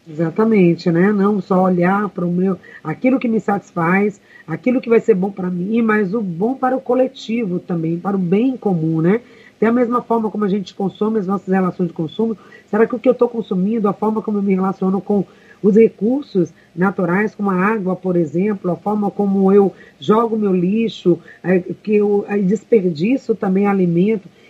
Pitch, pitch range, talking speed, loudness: 200 Hz, 185-220 Hz, 195 wpm, -17 LUFS